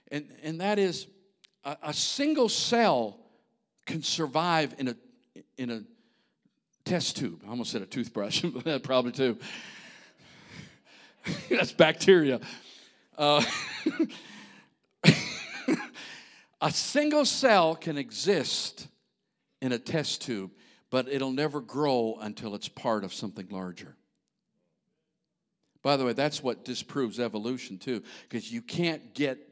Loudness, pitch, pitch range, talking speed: -29 LUFS, 150 Hz, 125-195 Hz, 115 wpm